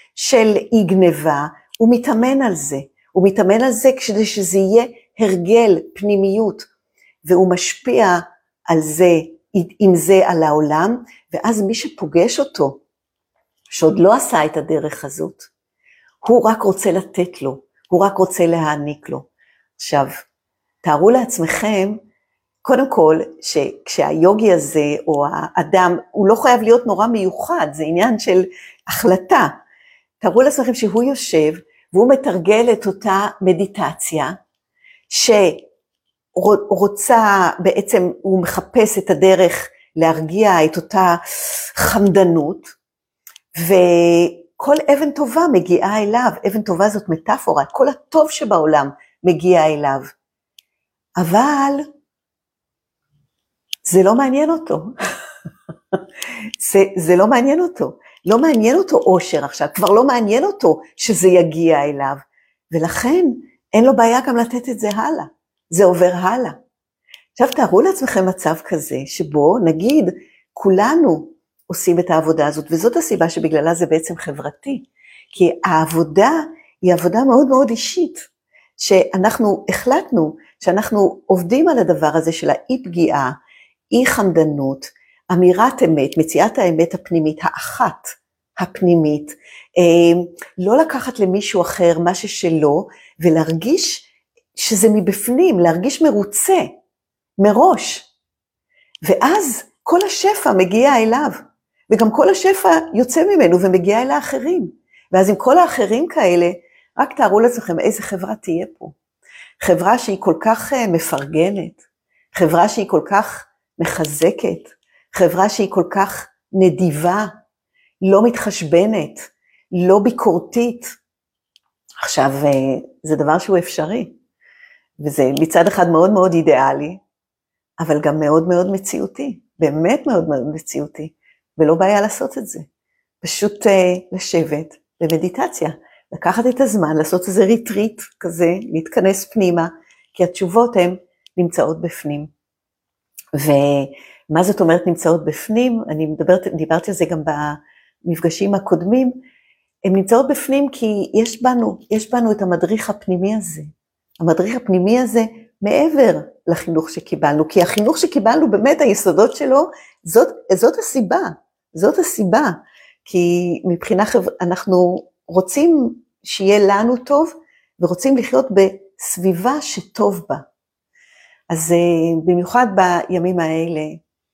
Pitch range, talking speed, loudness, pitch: 170-240 Hz, 115 wpm, -15 LUFS, 190 Hz